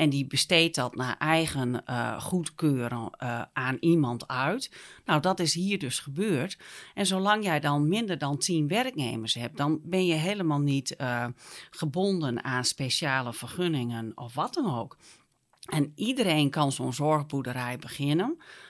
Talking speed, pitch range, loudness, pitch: 150 wpm, 125-170 Hz, -28 LUFS, 145 Hz